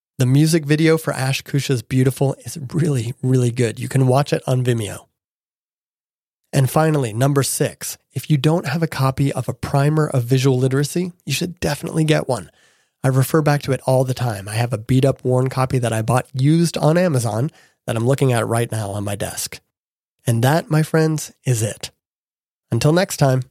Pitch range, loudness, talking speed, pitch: 125-150 Hz, -19 LUFS, 195 wpm, 135 Hz